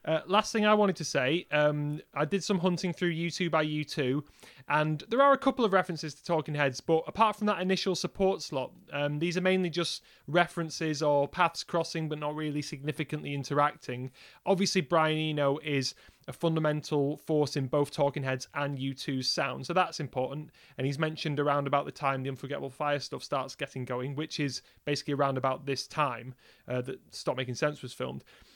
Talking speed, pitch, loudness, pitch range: 195 wpm, 150 Hz, -30 LUFS, 140-170 Hz